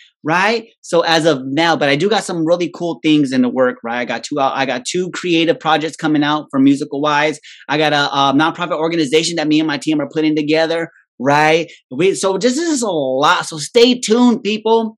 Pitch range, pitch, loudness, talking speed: 145-175 Hz, 155 Hz, -15 LUFS, 225 wpm